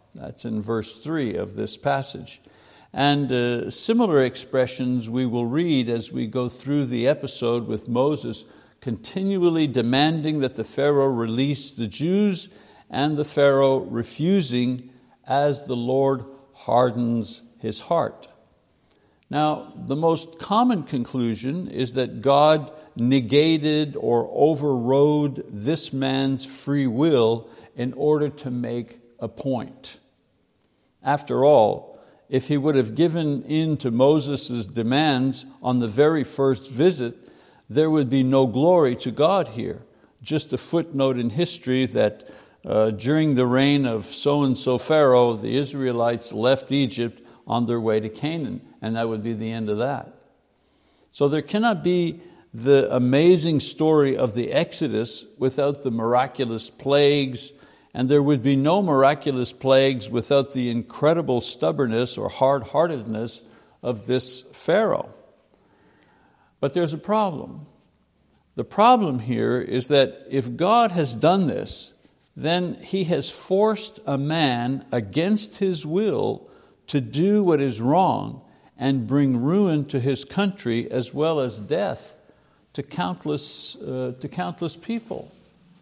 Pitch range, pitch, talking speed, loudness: 125-155 Hz, 135 Hz, 135 wpm, -22 LUFS